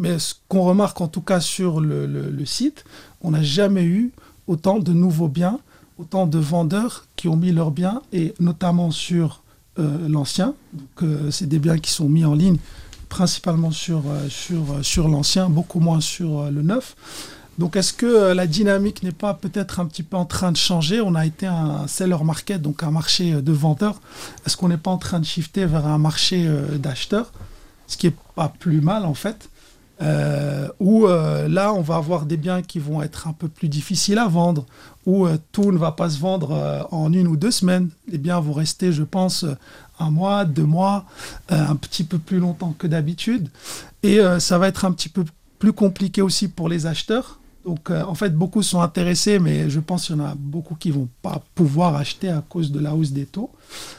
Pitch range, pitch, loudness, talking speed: 155-185 Hz, 170 Hz, -20 LUFS, 215 wpm